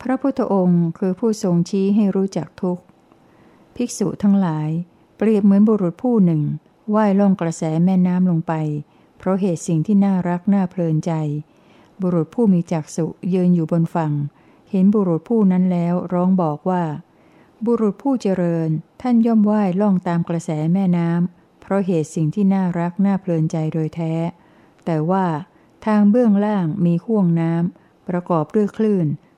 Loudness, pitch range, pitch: -19 LUFS, 165-200 Hz, 180 Hz